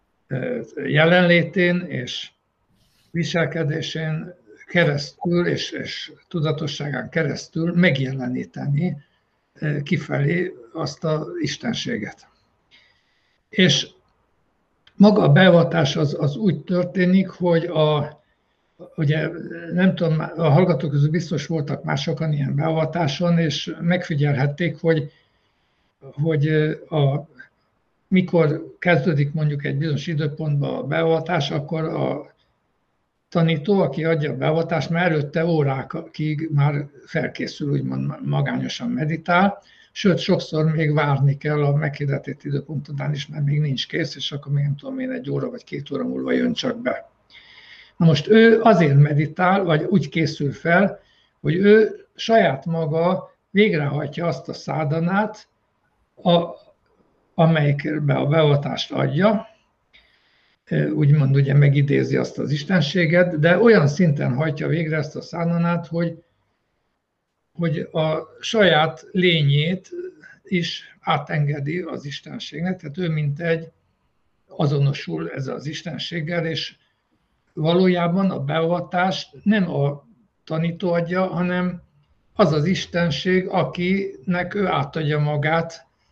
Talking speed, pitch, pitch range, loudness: 110 wpm, 160 Hz, 150-175 Hz, -21 LUFS